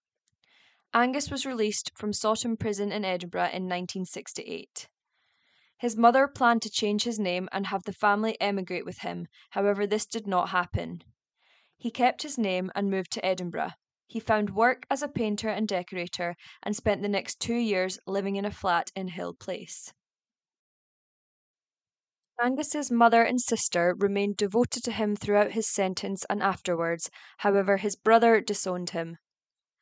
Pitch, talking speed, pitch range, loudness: 205 Hz, 155 wpm, 185-230 Hz, -28 LUFS